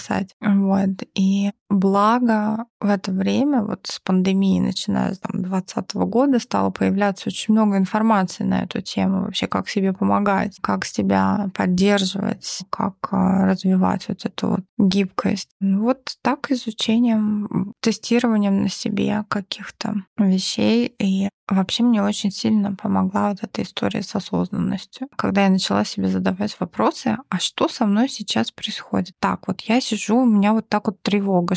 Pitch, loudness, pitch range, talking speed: 200 Hz, -21 LUFS, 190-220 Hz, 145 wpm